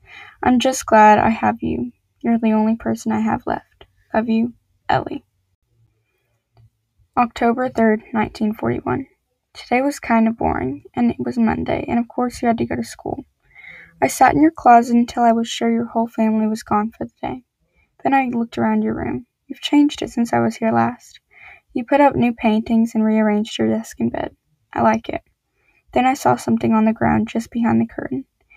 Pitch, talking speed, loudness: 220 Hz, 200 wpm, -18 LUFS